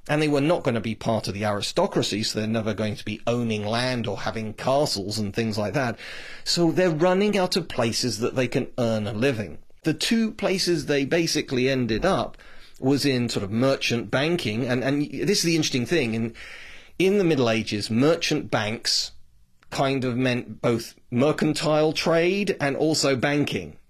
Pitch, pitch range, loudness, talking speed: 130 Hz, 110-155 Hz, -24 LUFS, 185 wpm